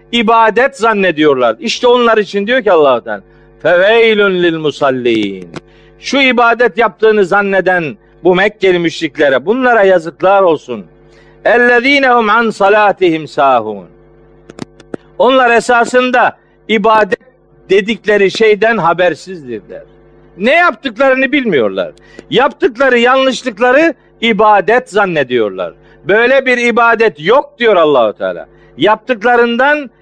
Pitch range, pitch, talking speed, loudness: 180-245 Hz, 220 Hz, 90 wpm, -10 LUFS